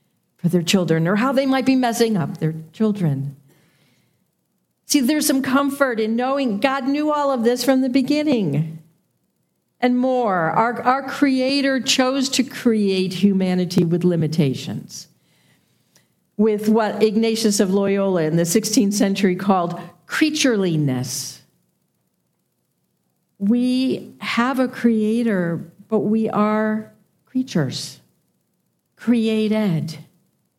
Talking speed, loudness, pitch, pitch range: 110 wpm, -19 LUFS, 215 Hz, 180-255 Hz